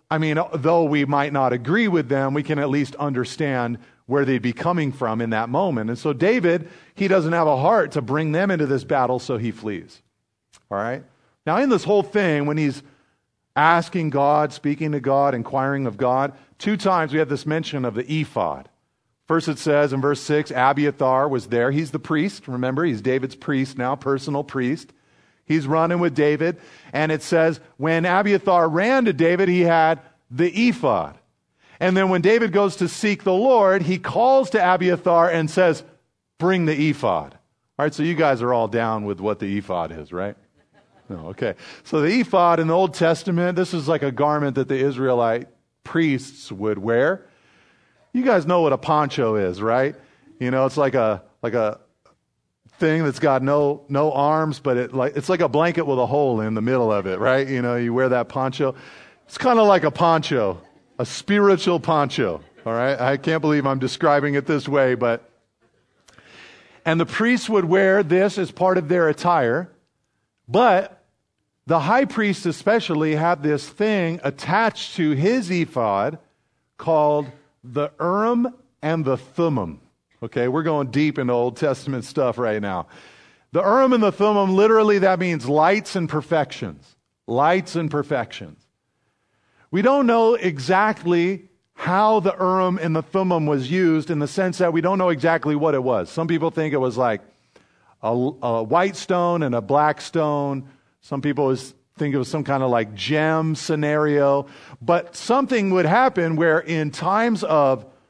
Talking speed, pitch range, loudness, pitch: 180 wpm, 130-175 Hz, -20 LUFS, 150 Hz